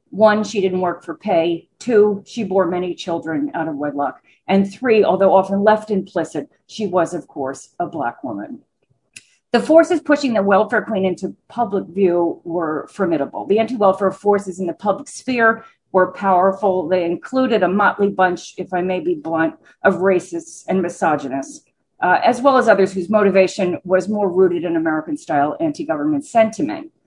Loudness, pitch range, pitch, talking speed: -18 LUFS, 175-220 Hz, 195 Hz, 175 wpm